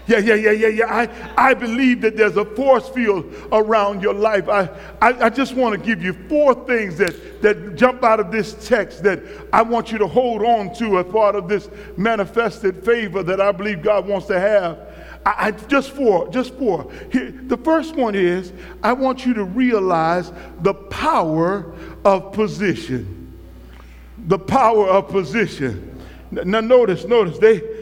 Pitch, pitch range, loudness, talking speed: 215 Hz, 195-235 Hz, -18 LUFS, 180 wpm